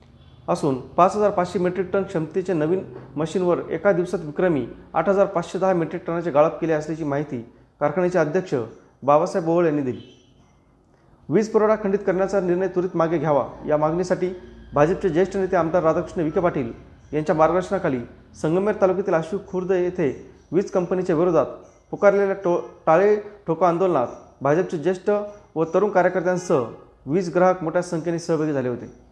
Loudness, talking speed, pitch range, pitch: -22 LUFS, 150 wpm, 160-190 Hz, 180 Hz